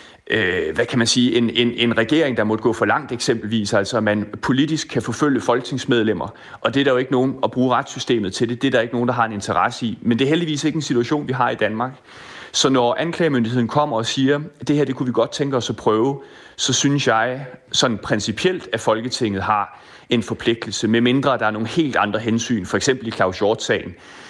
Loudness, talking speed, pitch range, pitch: -19 LUFS, 230 wpm, 115-135 Hz, 120 Hz